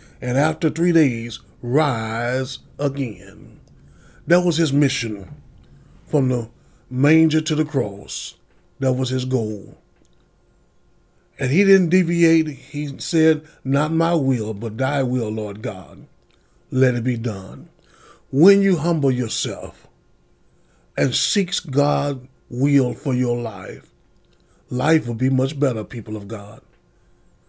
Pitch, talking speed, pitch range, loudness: 130 Hz, 125 wpm, 115-155 Hz, -20 LUFS